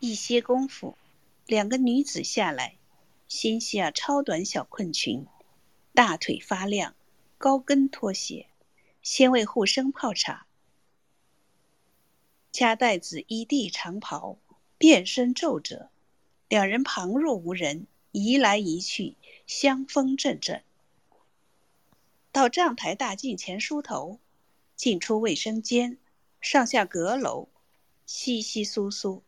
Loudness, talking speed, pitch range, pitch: -26 LUFS, 160 characters per minute, 205-270 Hz, 240 Hz